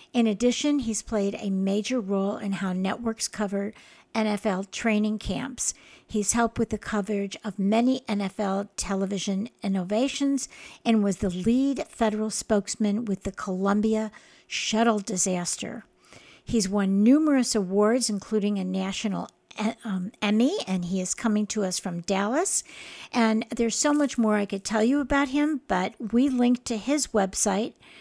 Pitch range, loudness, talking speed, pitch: 200-235 Hz, -26 LUFS, 150 wpm, 215 Hz